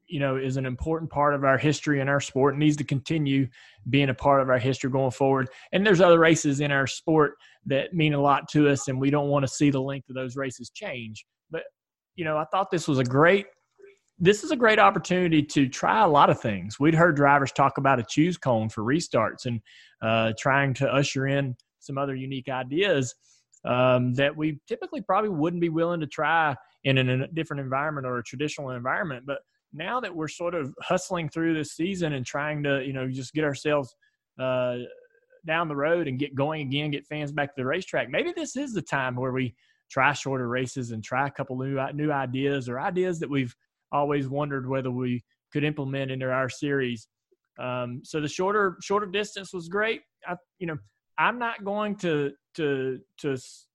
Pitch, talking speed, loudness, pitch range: 140 Hz, 210 wpm, -25 LUFS, 130-165 Hz